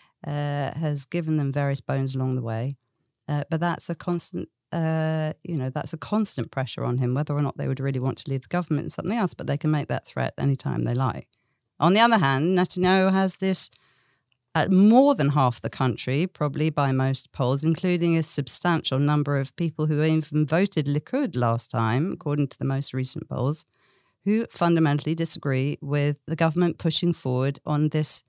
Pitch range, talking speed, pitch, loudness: 135-165 Hz, 195 wpm, 150 Hz, -24 LUFS